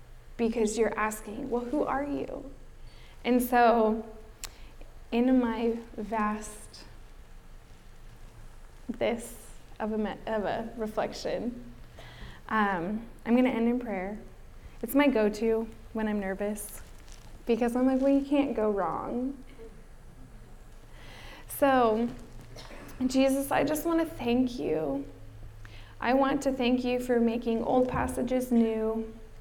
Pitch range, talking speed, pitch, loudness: 215-255 Hz, 120 wpm, 230 Hz, -29 LUFS